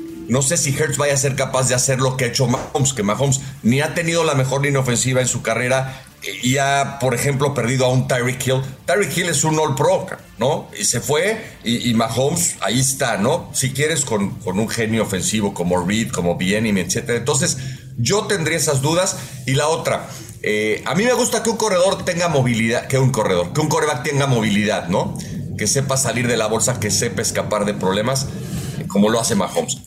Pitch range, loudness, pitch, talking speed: 115-150 Hz, -18 LUFS, 130 Hz, 215 wpm